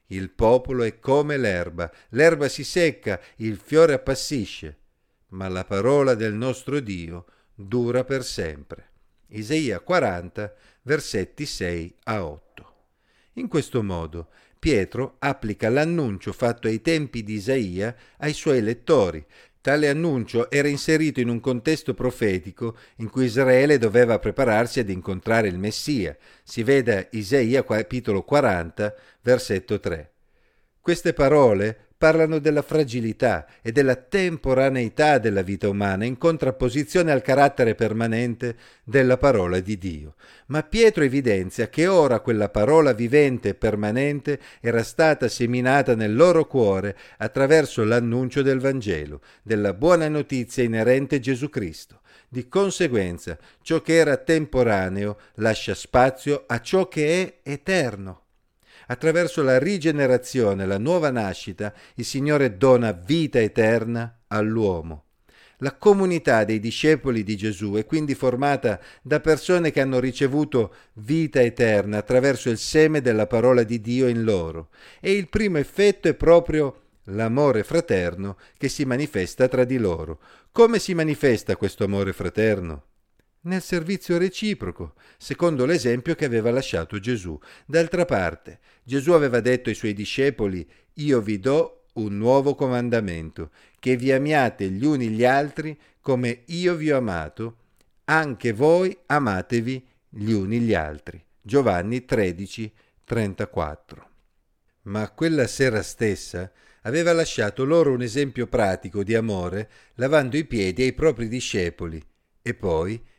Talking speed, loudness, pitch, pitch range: 130 wpm, -22 LUFS, 125 Hz, 105-145 Hz